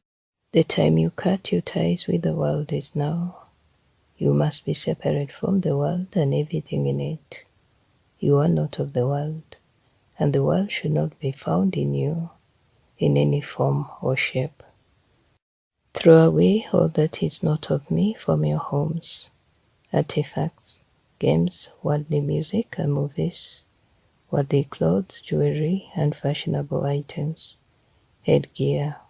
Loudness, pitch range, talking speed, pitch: -23 LUFS, 115-160 Hz, 135 wpm, 145 Hz